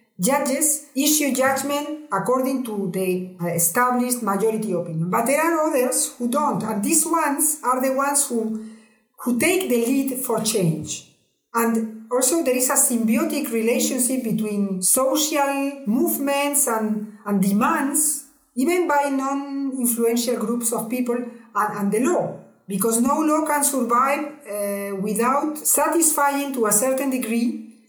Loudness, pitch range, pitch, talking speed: -21 LUFS, 220-280 Hz, 255 Hz, 140 wpm